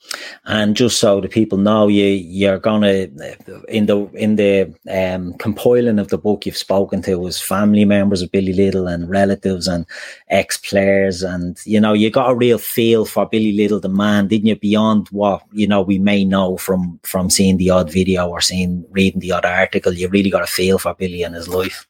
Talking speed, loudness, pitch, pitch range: 210 wpm, -16 LUFS, 100 Hz, 95-105 Hz